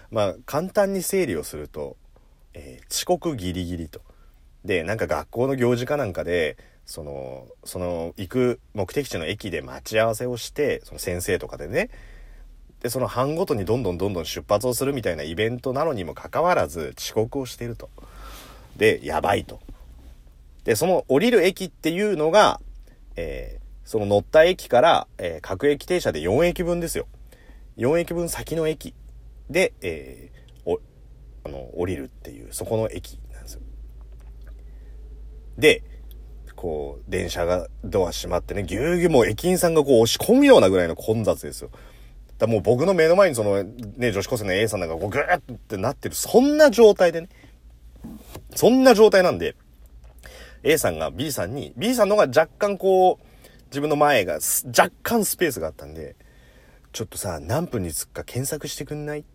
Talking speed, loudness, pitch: 325 characters per minute, -22 LUFS, 120 Hz